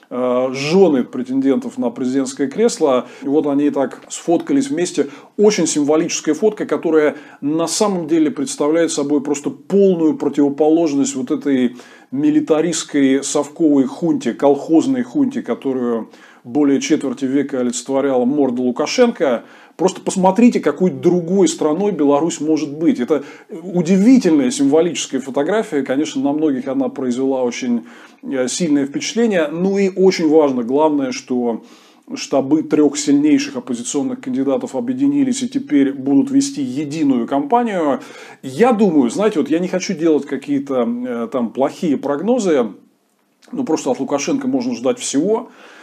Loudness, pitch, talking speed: -17 LUFS, 155 Hz, 125 wpm